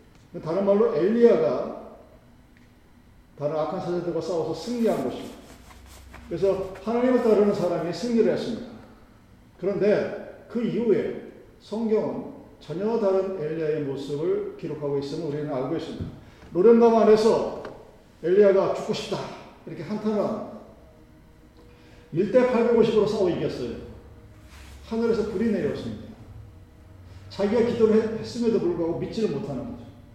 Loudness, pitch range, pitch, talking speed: -24 LUFS, 145-220 Hz, 190 Hz, 295 characters per minute